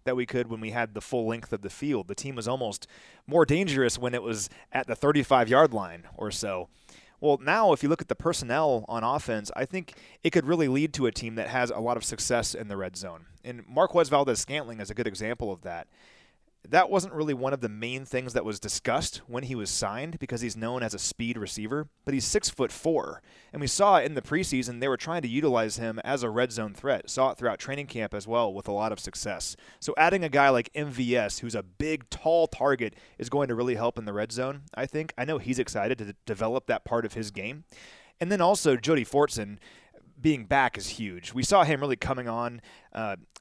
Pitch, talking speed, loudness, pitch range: 125 Hz, 240 wpm, -28 LUFS, 115-140 Hz